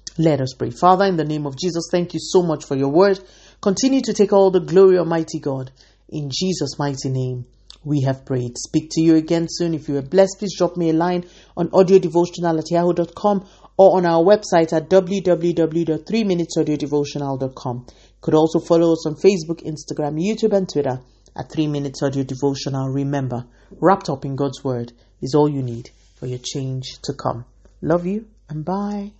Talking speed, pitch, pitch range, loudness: 185 wpm, 160 Hz, 140-180 Hz, -19 LUFS